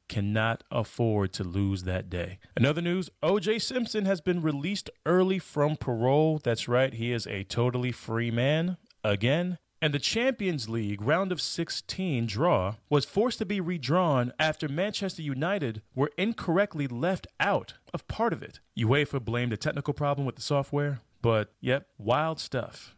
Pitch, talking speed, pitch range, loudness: 145 Hz, 160 wpm, 115-180 Hz, -29 LUFS